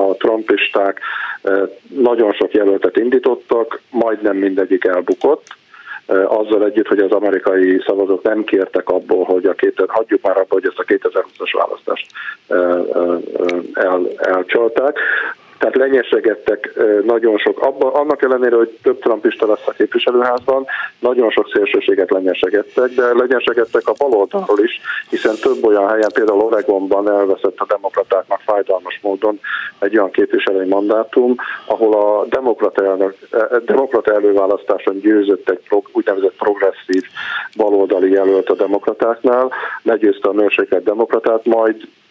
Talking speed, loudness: 125 wpm, -15 LUFS